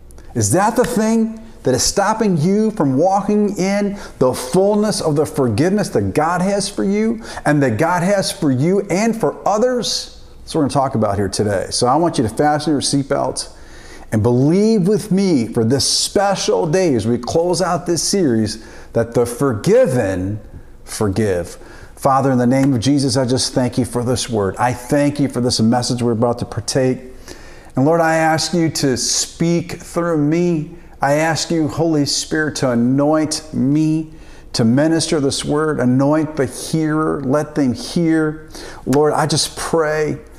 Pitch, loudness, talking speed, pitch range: 150 Hz, -17 LUFS, 175 wpm, 130-175 Hz